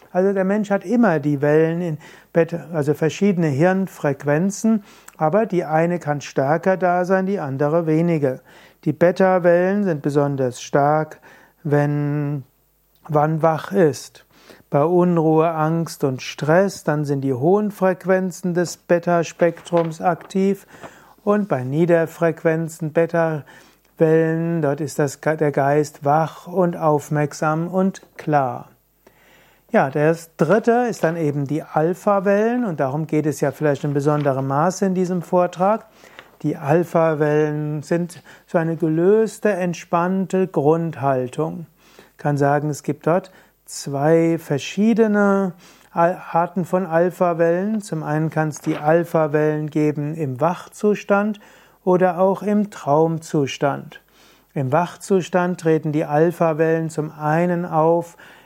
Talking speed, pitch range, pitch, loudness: 120 wpm, 150-185 Hz, 165 Hz, -20 LUFS